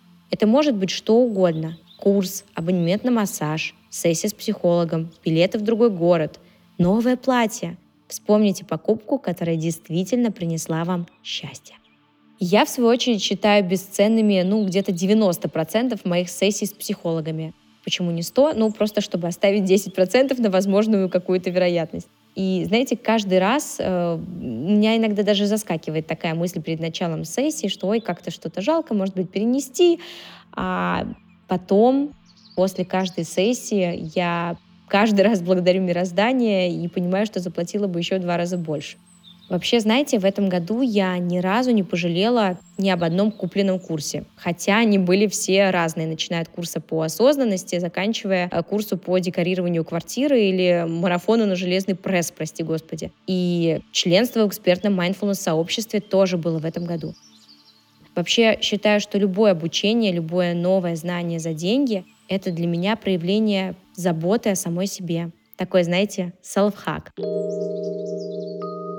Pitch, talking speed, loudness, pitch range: 190 Hz, 140 wpm, -21 LUFS, 175-210 Hz